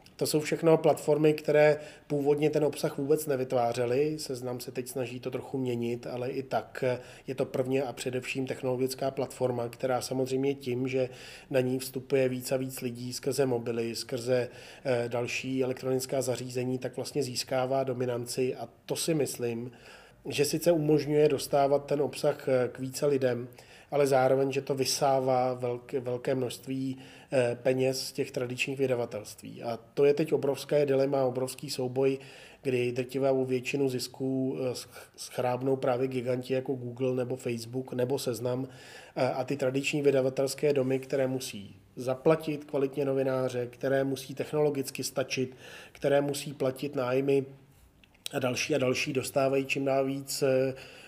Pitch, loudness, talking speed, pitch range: 130 Hz, -30 LUFS, 140 wpm, 125-140 Hz